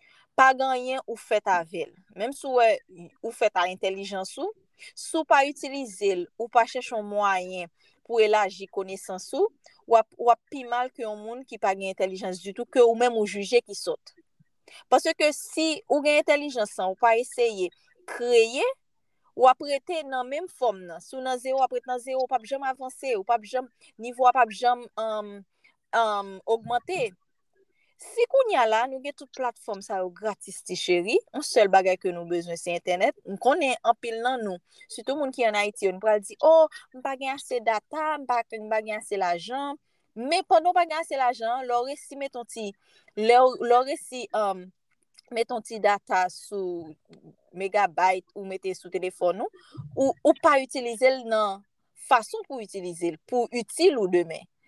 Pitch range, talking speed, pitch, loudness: 200-275 Hz, 175 wpm, 235 Hz, -25 LUFS